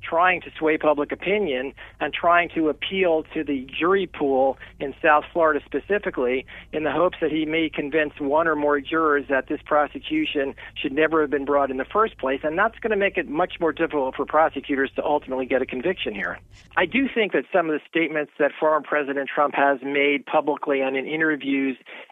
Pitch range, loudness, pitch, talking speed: 140-160 Hz, -23 LUFS, 150 Hz, 205 wpm